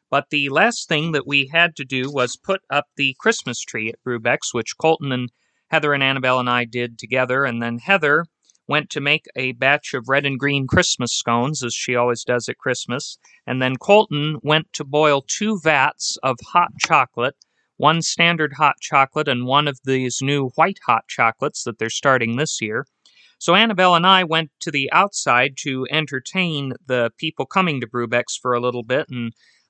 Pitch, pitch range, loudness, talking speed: 140 Hz, 125-160 Hz, -19 LUFS, 190 wpm